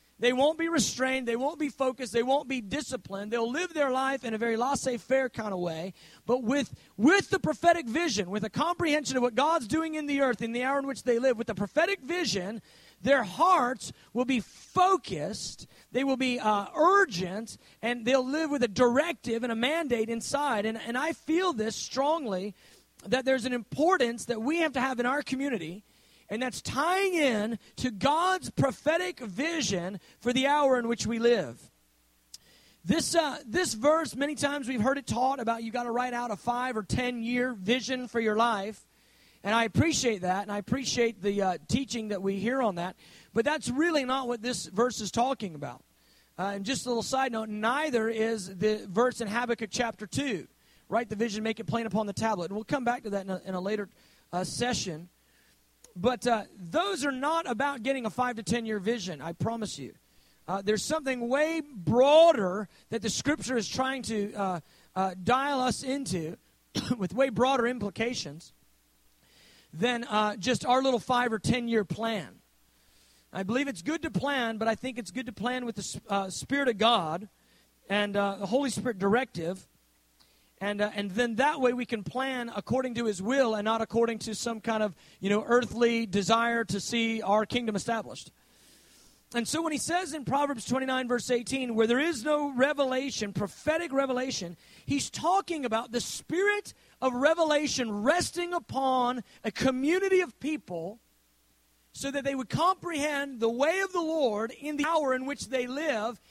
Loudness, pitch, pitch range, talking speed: -29 LUFS, 240 Hz, 210-275 Hz, 190 wpm